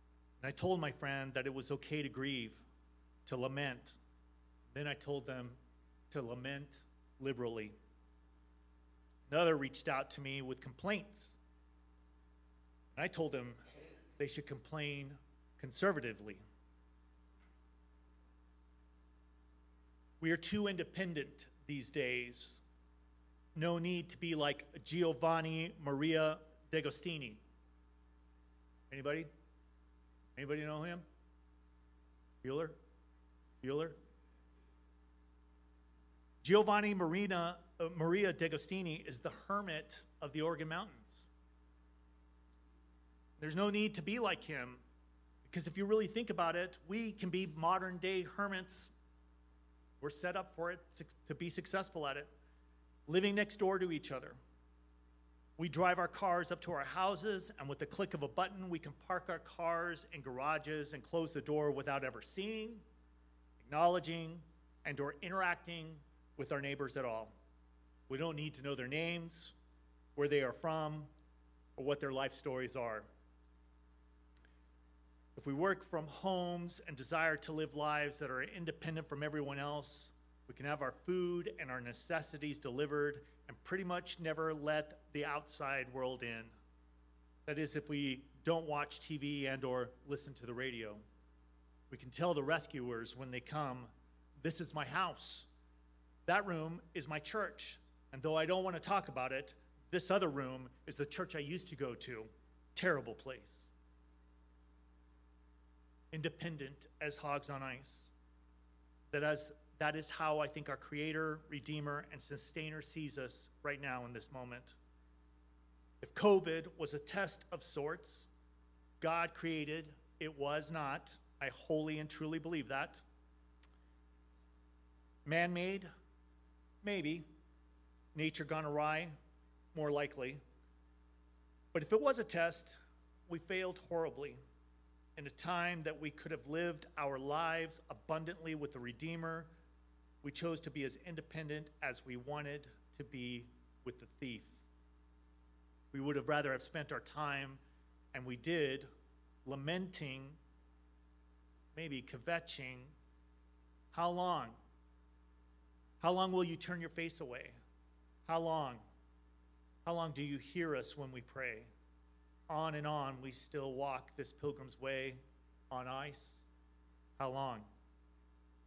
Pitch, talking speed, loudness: 135 Hz, 135 wpm, -41 LUFS